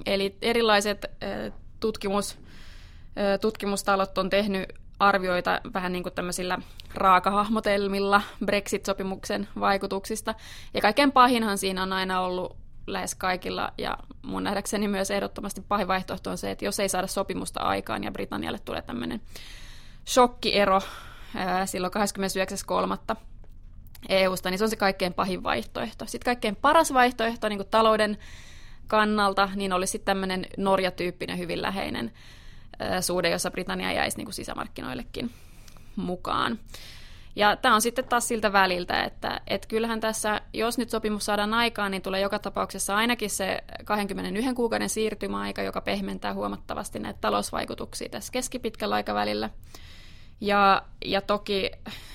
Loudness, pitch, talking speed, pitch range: -26 LUFS, 195 Hz, 130 wpm, 180-210 Hz